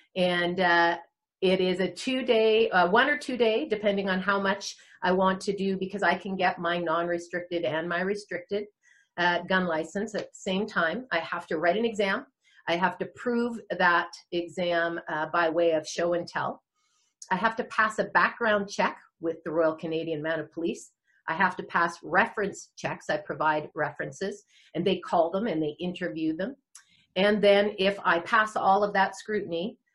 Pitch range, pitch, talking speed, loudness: 170-205 Hz, 185 Hz, 190 wpm, -27 LUFS